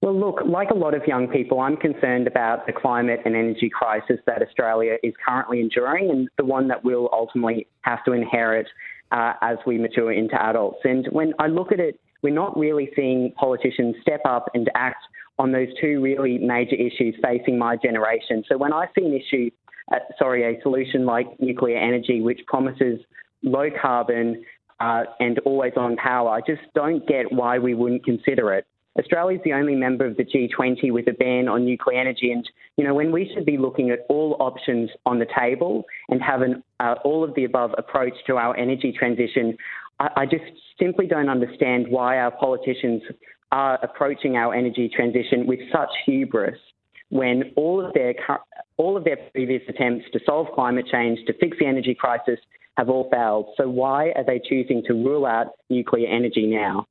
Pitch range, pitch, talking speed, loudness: 120-135 Hz, 125 Hz, 190 wpm, -22 LUFS